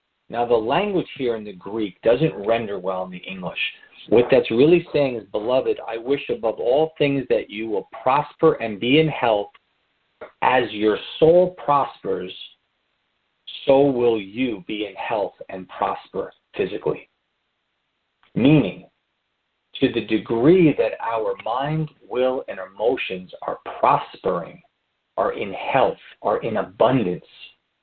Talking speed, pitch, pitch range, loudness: 135 wpm, 125 Hz, 110-150 Hz, -21 LUFS